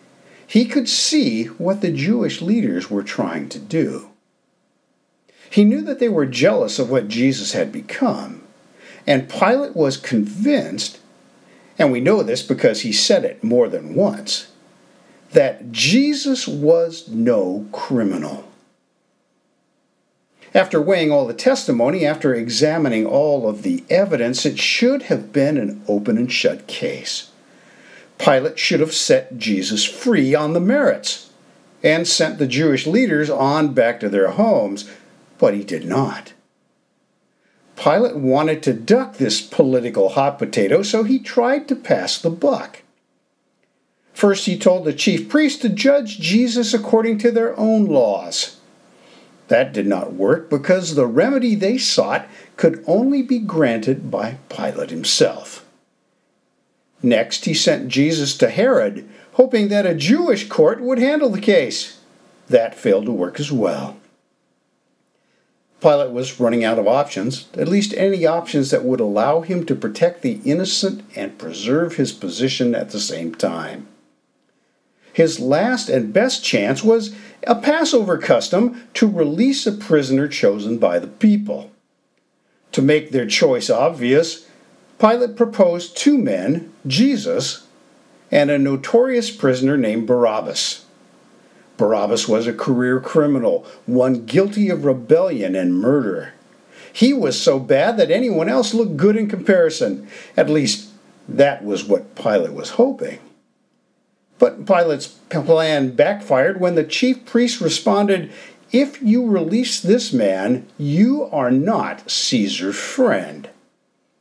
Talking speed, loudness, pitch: 135 wpm, -18 LUFS, 200 Hz